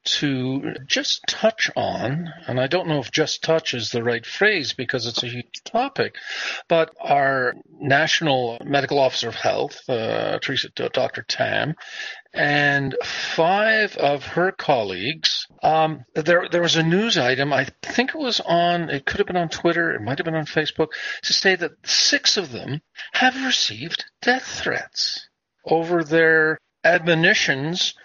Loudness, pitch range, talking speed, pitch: -21 LUFS, 140-190 Hz, 160 wpm, 160 Hz